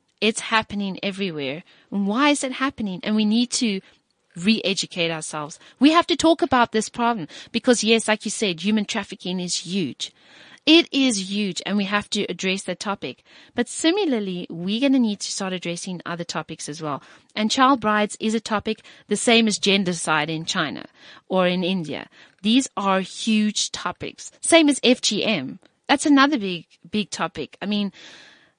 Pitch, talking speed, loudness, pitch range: 210 Hz, 175 wpm, -22 LUFS, 180-240 Hz